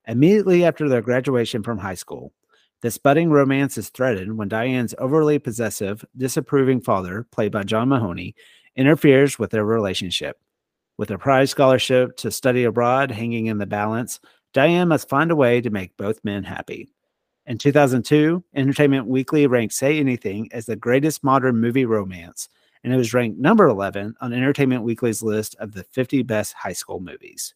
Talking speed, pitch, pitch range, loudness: 170 wpm, 125 Hz, 110-135 Hz, -20 LUFS